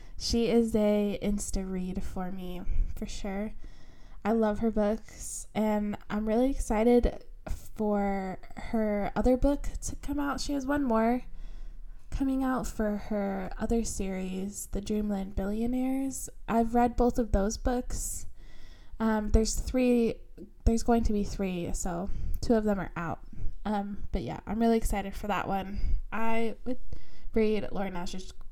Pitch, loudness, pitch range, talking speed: 215 Hz, -31 LUFS, 200-235 Hz, 150 wpm